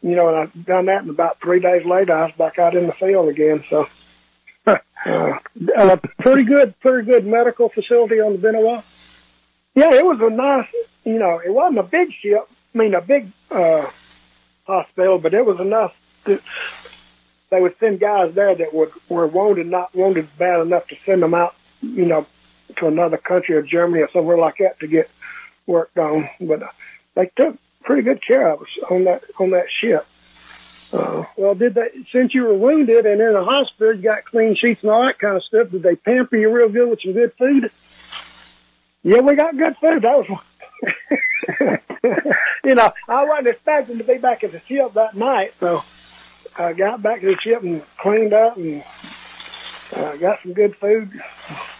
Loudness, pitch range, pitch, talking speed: -17 LUFS, 170-235 Hz, 200 Hz, 195 wpm